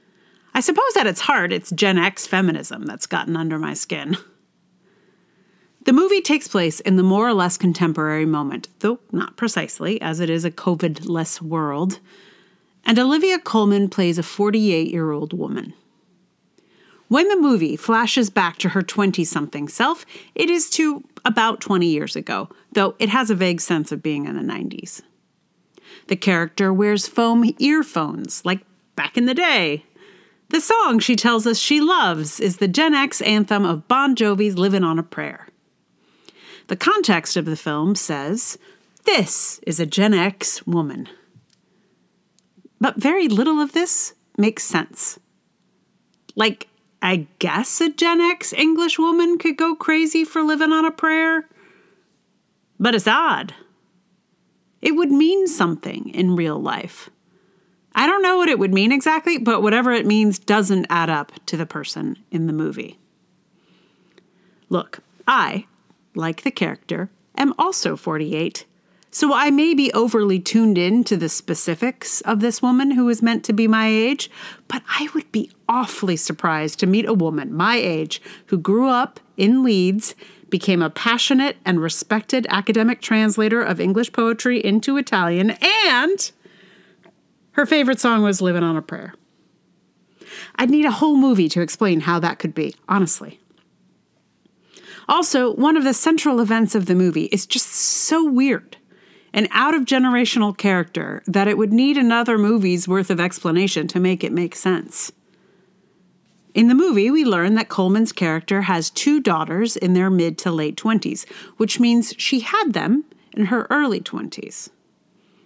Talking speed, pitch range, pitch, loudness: 155 wpm, 180-260 Hz, 210 Hz, -19 LUFS